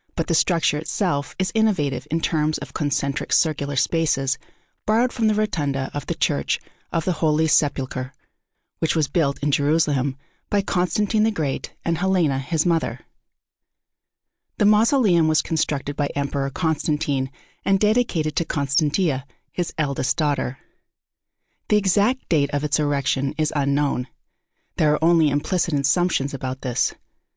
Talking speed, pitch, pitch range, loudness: 145 wpm, 155 Hz, 140-175 Hz, -22 LUFS